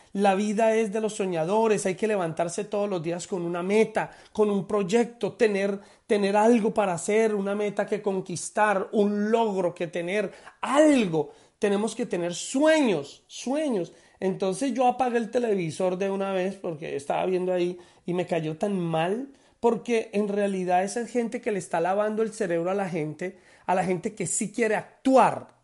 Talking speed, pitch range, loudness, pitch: 175 wpm, 185-225 Hz, -26 LUFS, 205 Hz